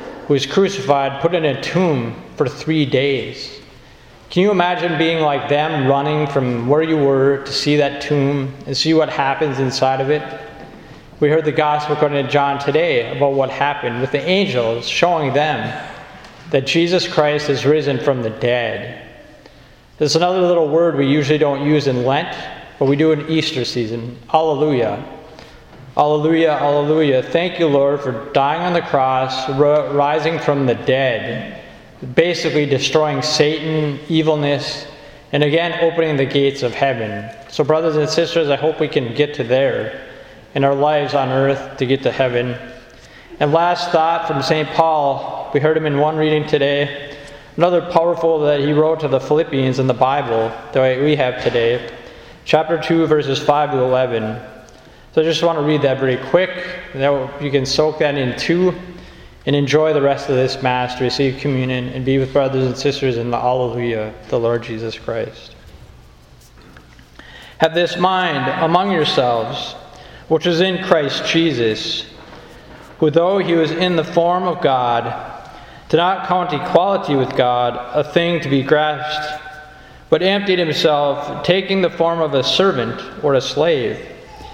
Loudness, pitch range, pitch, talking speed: -17 LUFS, 135-160 Hz, 145 Hz, 165 wpm